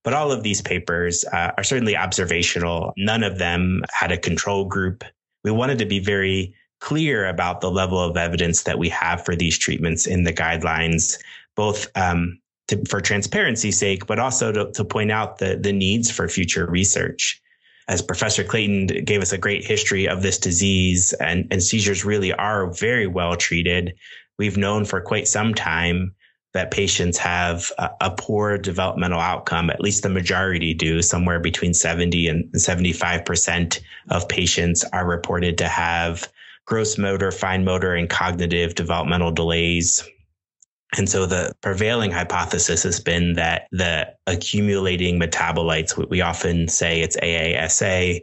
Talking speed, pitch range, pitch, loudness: 155 wpm, 85-100 Hz, 90 Hz, -20 LUFS